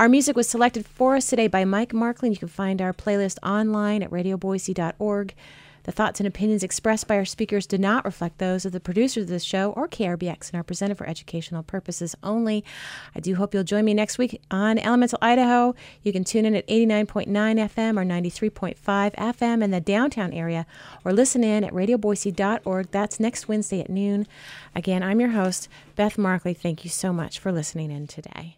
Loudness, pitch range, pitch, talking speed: -24 LUFS, 185-220 Hz, 200 Hz, 200 wpm